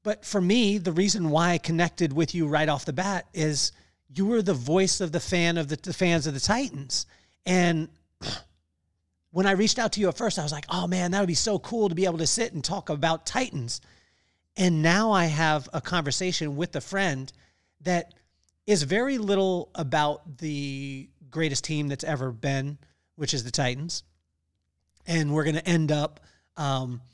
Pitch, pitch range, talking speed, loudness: 160 Hz, 140-185 Hz, 195 wpm, -26 LUFS